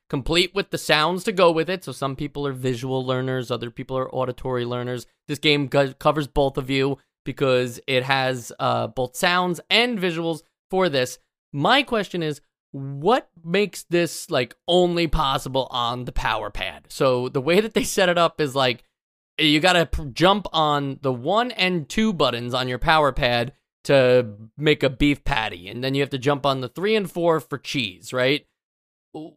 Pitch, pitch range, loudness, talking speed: 140 Hz, 130-170 Hz, -22 LUFS, 190 wpm